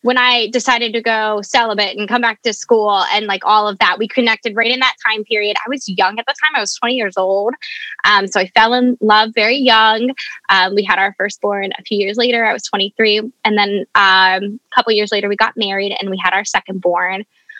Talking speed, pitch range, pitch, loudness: 240 wpm, 200-240 Hz, 215 Hz, -14 LUFS